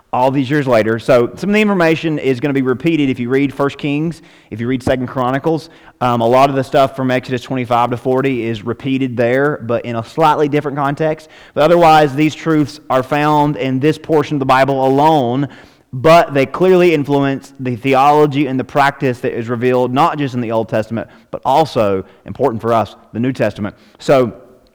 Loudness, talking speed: -14 LUFS, 205 wpm